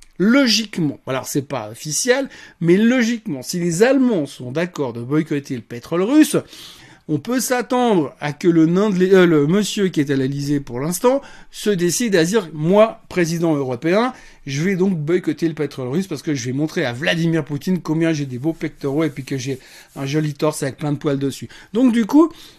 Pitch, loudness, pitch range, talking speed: 160 Hz, -19 LUFS, 145-195 Hz, 200 wpm